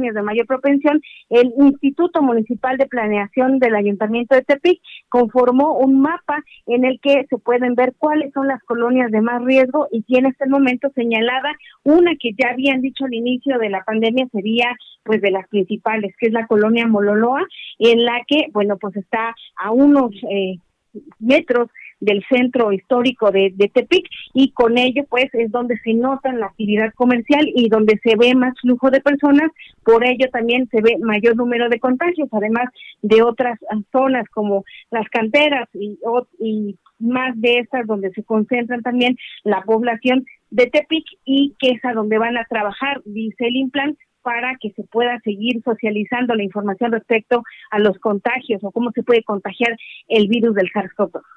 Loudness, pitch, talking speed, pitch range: -17 LUFS, 240 Hz, 175 wpm, 220-260 Hz